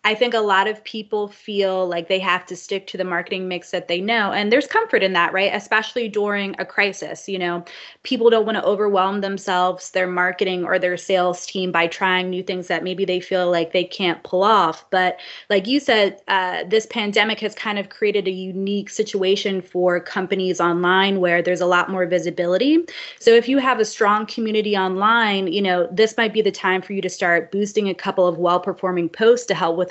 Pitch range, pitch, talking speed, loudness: 180-210 Hz, 195 Hz, 215 wpm, -19 LUFS